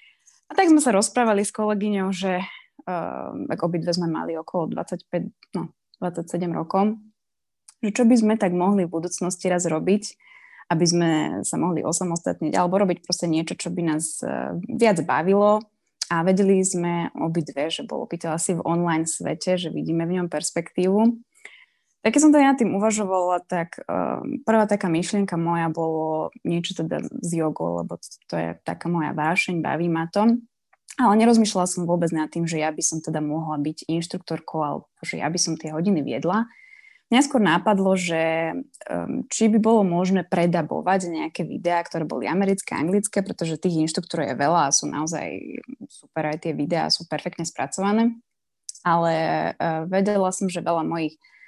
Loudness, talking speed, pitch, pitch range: -23 LUFS, 170 wpm, 180 Hz, 165-210 Hz